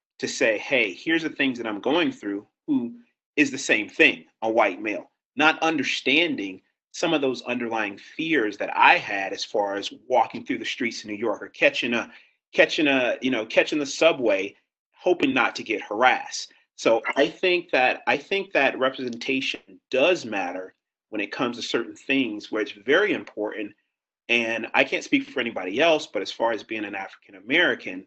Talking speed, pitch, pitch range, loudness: 190 wpm, 140 Hz, 120-195 Hz, -23 LUFS